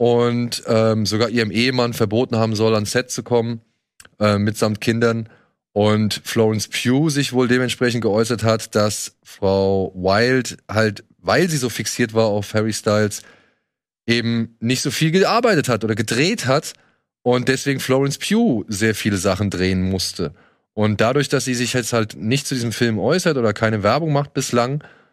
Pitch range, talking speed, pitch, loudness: 110-125 Hz, 165 wpm, 115 Hz, -19 LUFS